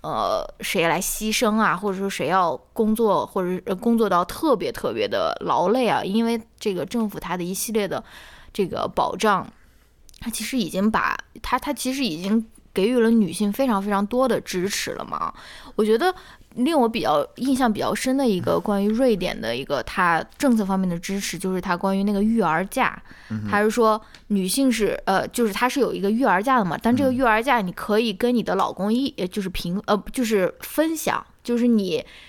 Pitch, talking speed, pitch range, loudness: 220 Hz, 290 characters per minute, 195-245 Hz, -22 LUFS